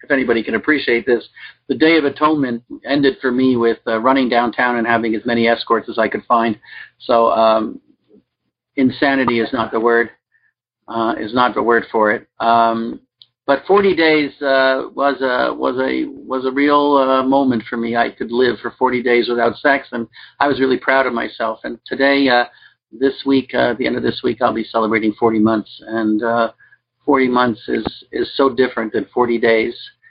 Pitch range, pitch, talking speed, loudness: 115-135 Hz, 125 Hz, 195 wpm, -16 LUFS